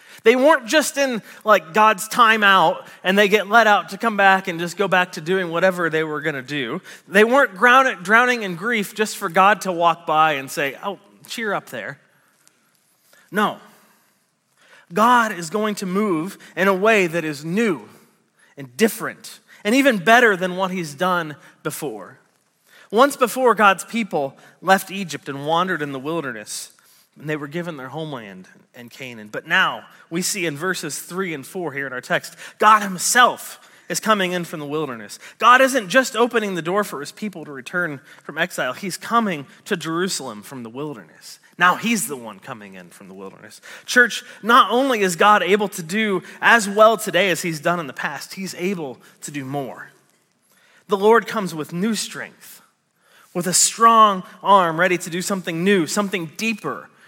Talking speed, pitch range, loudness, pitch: 185 wpm, 160-215 Hz, -18 LUFS, 190 Hz